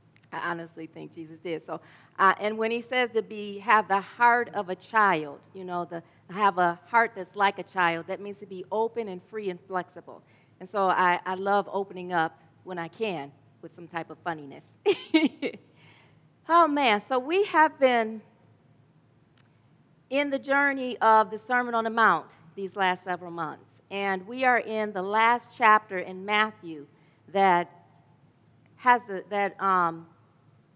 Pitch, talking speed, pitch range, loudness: 185 Hz, 170 wpm, 165-220 Hz, -26 LUFS